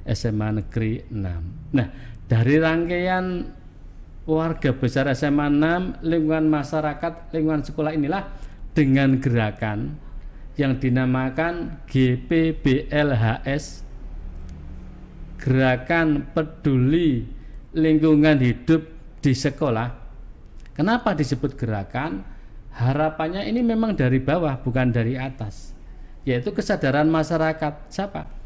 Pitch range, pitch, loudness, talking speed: 125-160 Hz, 140 Hz, -22 LUFS, 85 wpm